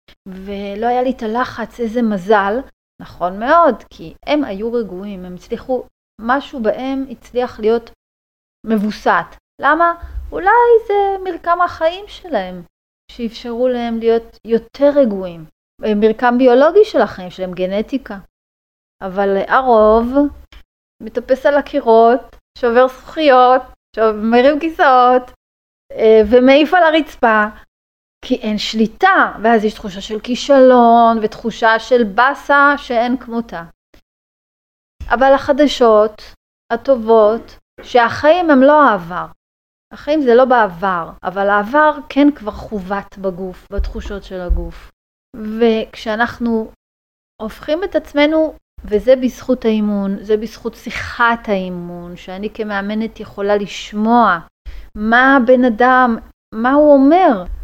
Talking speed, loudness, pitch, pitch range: 105 wpm, -14 LUFS, 230 Hz, 210-265 Hz